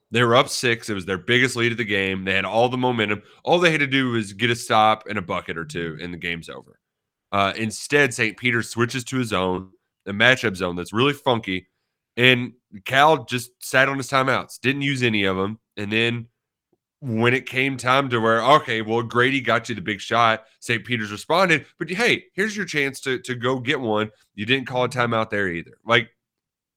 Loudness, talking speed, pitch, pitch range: -21 LUFS, 220 wpm, 120 Hz, 105-130 Hz